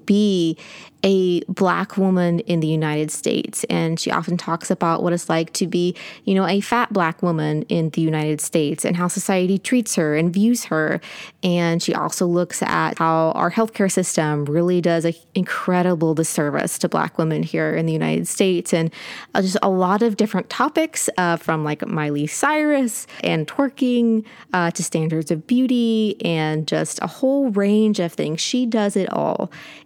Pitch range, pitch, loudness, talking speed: 160-205 Hz, 180 Hz, -20 LUFS, 175 wpm